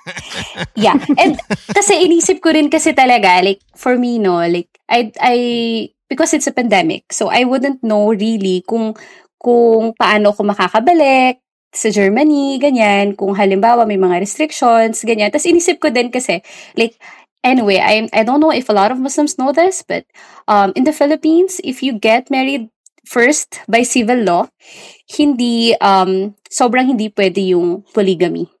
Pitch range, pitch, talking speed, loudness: 210-290 Hz, 240 Hz, 160 wpm, -13 LUFS